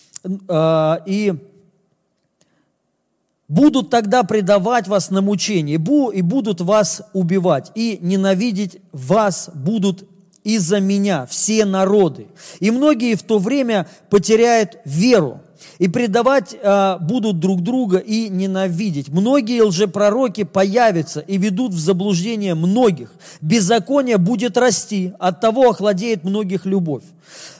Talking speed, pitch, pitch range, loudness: 105 wpm, 200 Hz, 185-225 Hz, -17 LUFS